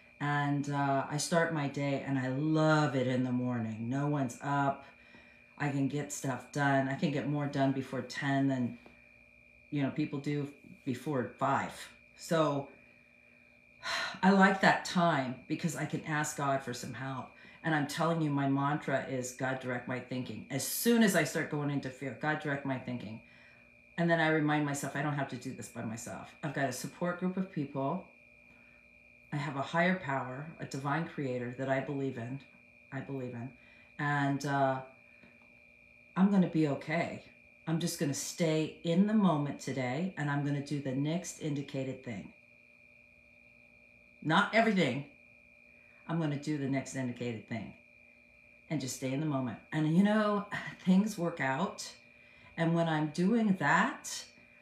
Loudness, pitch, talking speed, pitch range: -33 LUFS, 140 Hz, 170 wpm, 130-155 Hz